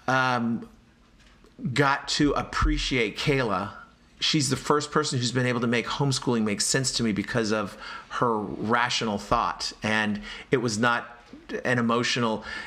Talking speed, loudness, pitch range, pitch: 140 wpm, -25 LUFS, 115-135 Hz, 125 Hz